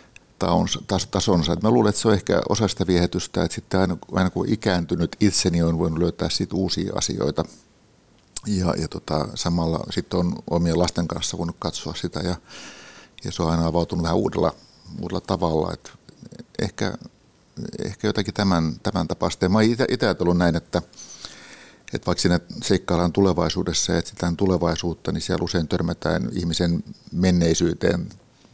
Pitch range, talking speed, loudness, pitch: 85-95 Hz, 145 wpm, -23 LUFS, 90 Hz